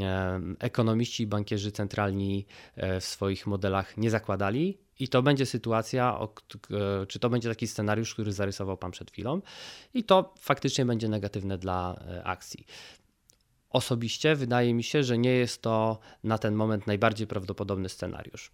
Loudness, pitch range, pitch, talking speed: -29 LUFS, 100-120 Hz, 110 Hz, 140 wpm